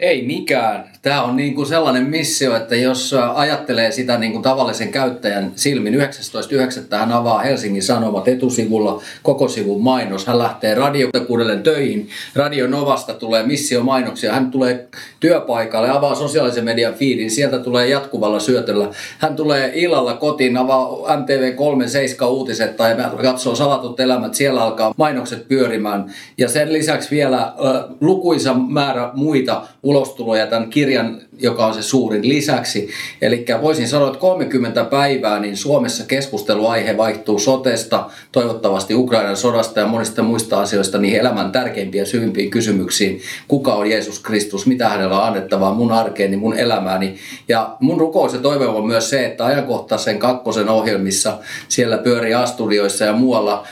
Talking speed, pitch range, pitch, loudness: 145 wpm, 110-135 Hz, 125 Hz, -17 LUFS